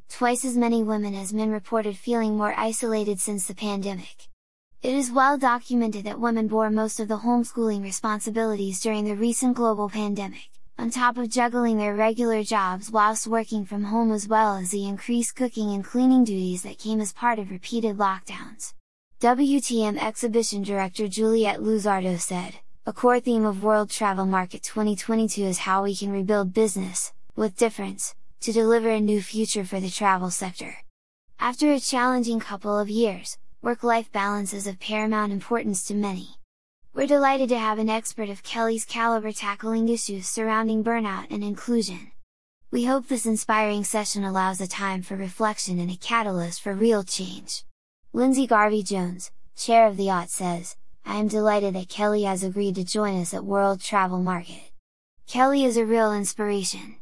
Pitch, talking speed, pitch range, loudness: 215 Hz, 170 wpm, 200-230 Hz, -24 LUFS